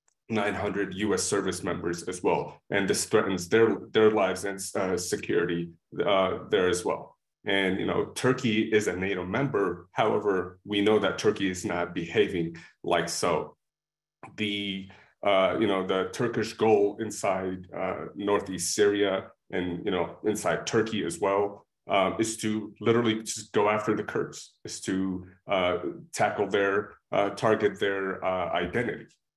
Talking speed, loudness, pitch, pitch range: 150 wpm, -27 LUFS, 100 Hz, 95-110 Hz